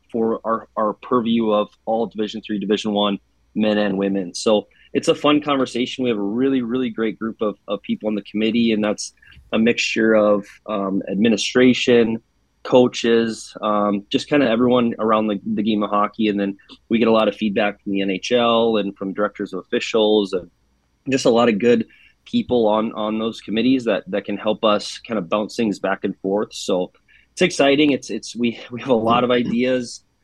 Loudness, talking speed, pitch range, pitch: -20 LUFS, 200 wpm, 105-120 Hz, 110 Hz